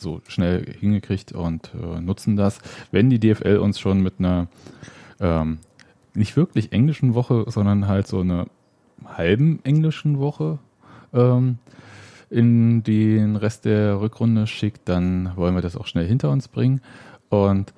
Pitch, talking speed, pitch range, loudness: 105 Hz, 140 wpm, 95-120 Hz, -21 LUFS